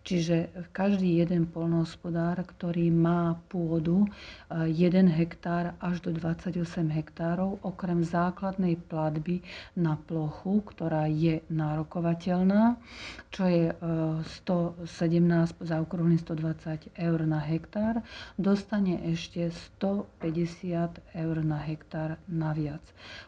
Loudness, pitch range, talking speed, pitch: -29 LUFS, 165-180 Hz, 95 wpm, 170 Hz